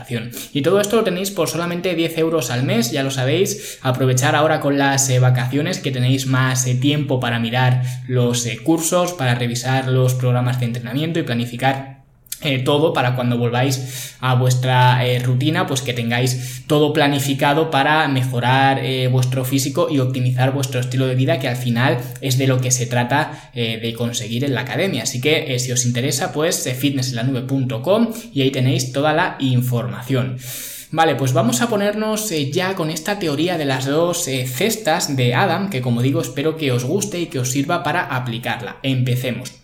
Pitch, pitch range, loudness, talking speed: 130 Hz, 125-150 Hz, -18 LUFS, 190 wpm